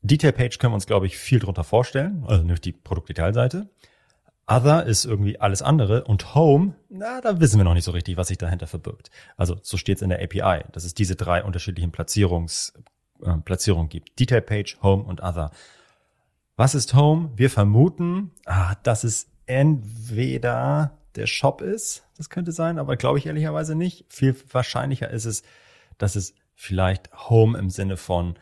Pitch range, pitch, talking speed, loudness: 95-140 Hz, 105 Hz, 175 wpm, -22 LUFS